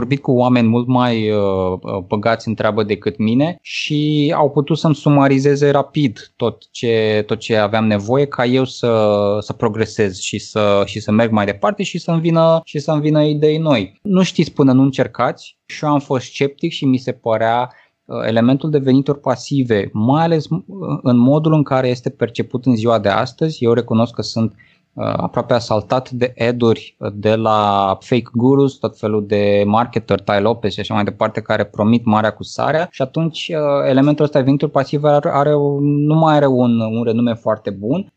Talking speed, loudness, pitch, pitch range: 180 wpm, -16 LUFS, 125 Hz, 110-145 Hz